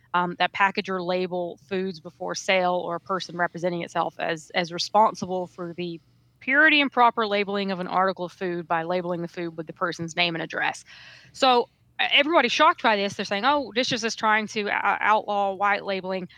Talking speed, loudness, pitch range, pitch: 195 wpm, -24 LUFS, 175-210 Hz, 185 Hz